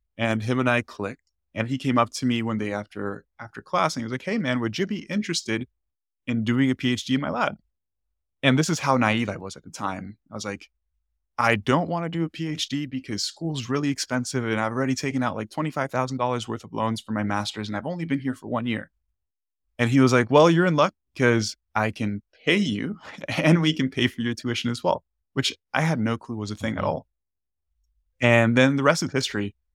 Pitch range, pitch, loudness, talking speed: 105-135 Hz, 120 Hz, -24 LUFS, 235 wpm